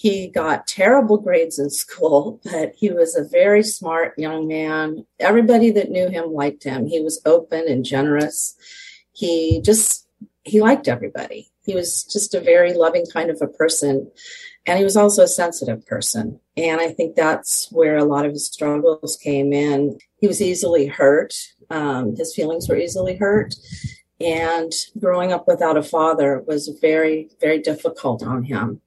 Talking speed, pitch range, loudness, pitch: 170 wpm, 155-210 Hz, -18 LUFS, 165 Hz